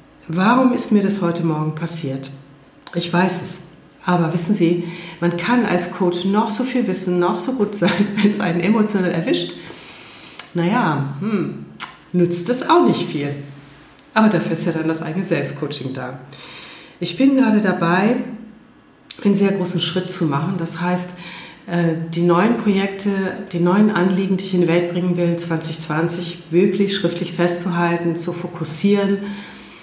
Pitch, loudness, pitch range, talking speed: 175 Hz, -19 LUFS, 170-200 Hz, 155 wpm